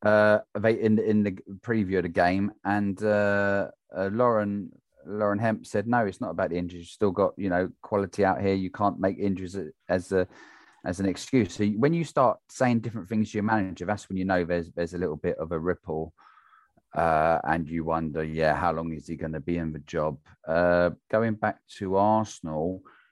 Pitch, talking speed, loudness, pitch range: 95 Hz, 215 wpm, -27 LUFS, 90-105 Hz